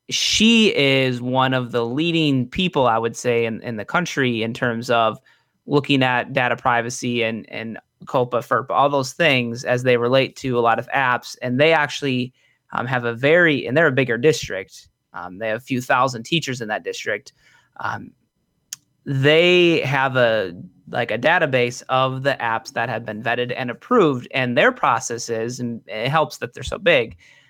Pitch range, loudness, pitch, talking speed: 120-140 Hz, -19 LUFS, 125 Hz, 185 wpm